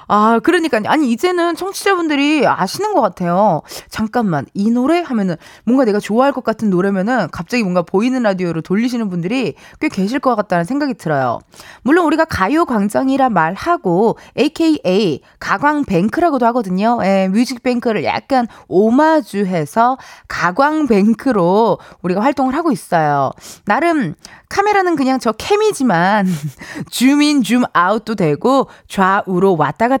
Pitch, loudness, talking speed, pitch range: 230 Hz, -15 LUFS, 330 characters per minute, 195-285 Hz